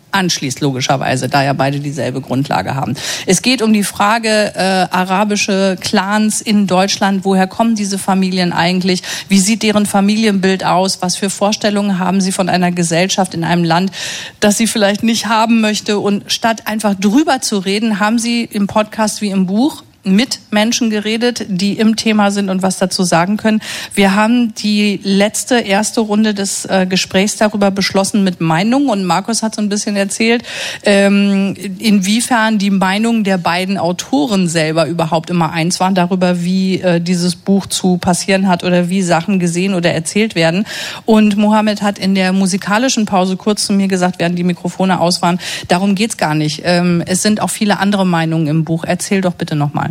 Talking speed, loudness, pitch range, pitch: 175 wpm, -14 LUFS, 180-210 Hz, 195 Hz